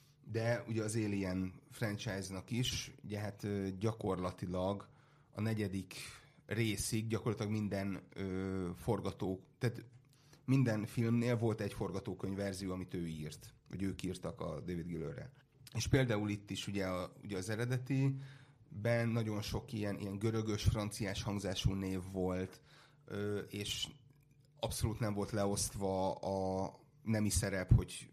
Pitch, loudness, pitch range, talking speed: 105 Hz, -39 LUFS, 95-120 Hz, 130 wpm